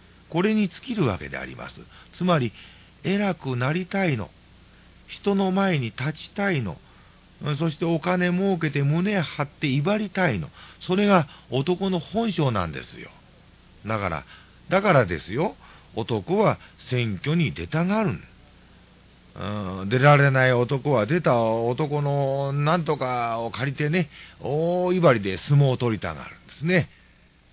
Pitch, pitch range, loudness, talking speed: 145 Hz, 120-180 Hz, -24 LUFS, 260 characters per minute